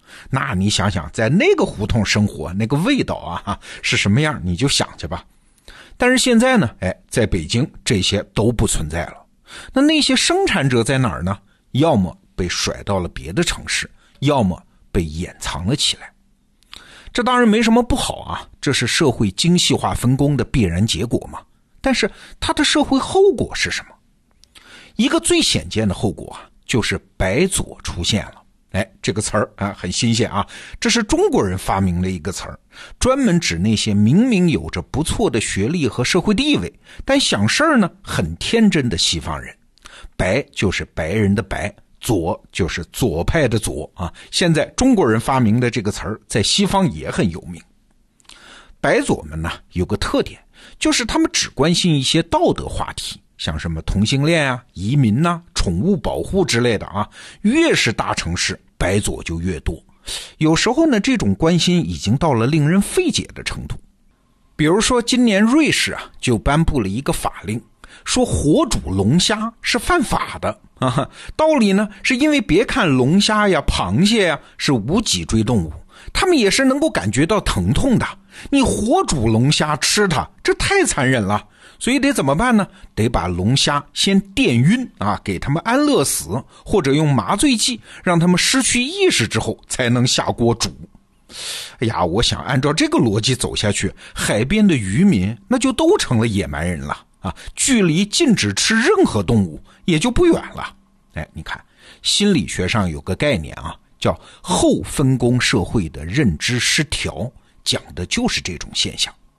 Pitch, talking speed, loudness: 135 Hz, 250 characters per minute, -18 LUFS